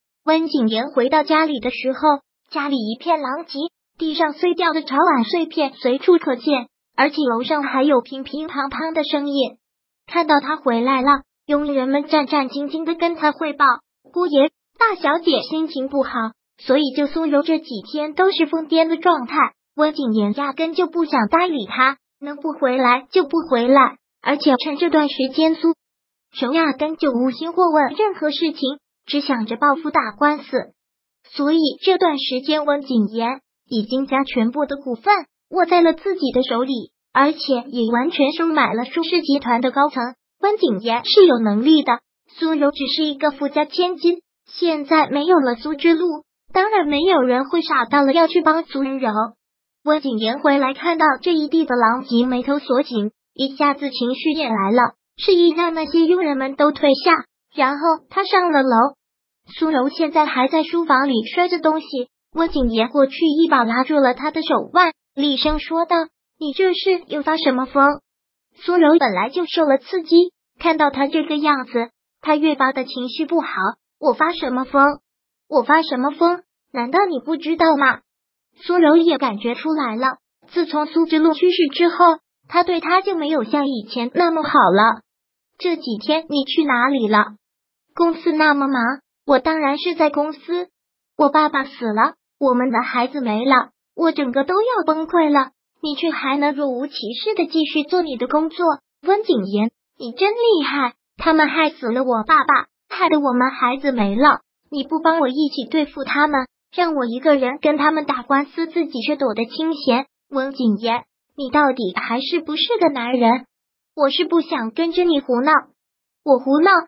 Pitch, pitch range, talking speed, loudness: 295 Hz, 260-325 Hz, 255 characters per minute, -18 LUFS